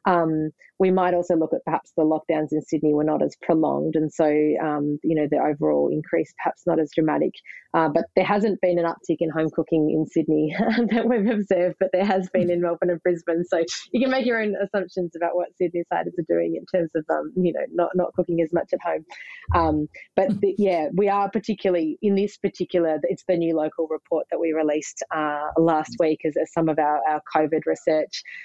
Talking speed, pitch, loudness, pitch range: 220 wpm, 170 Hz, -23 LUFS, 155-185 Hz